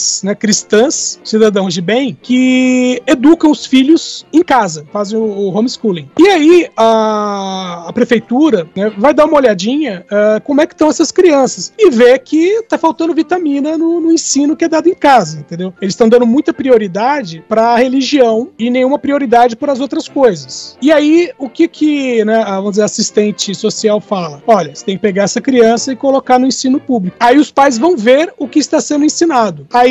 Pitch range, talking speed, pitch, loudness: 215-300 Hz, 195 wpm, 250 Hz, -11 LUFS